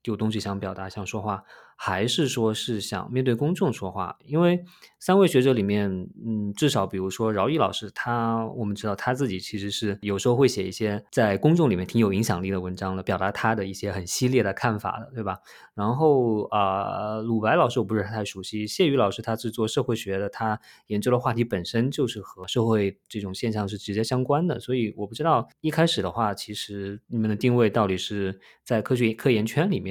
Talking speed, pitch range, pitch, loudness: 325 characters per minute, 100-125 Hz, 110 Hz, -25 LUFS